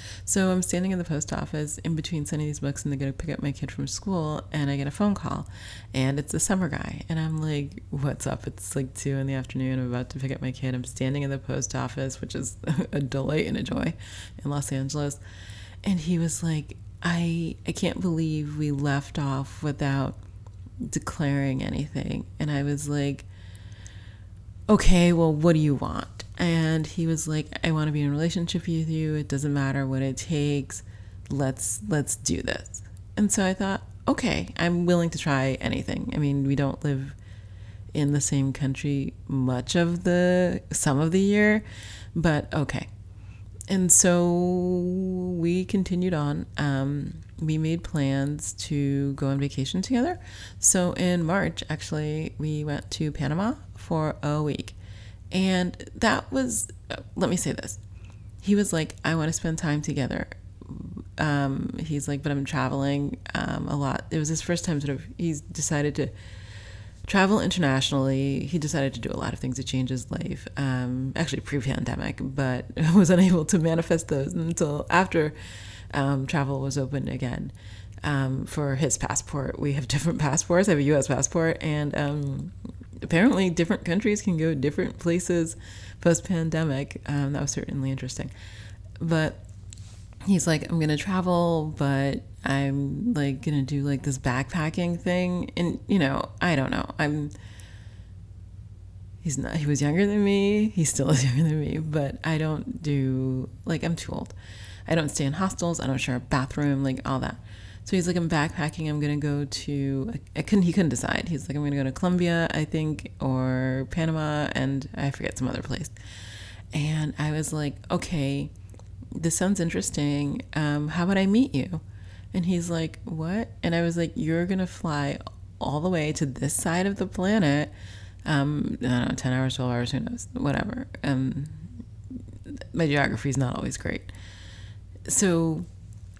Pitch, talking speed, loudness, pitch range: 145 Hz, 175 wpm, -26 LUFS, 125-165 Hz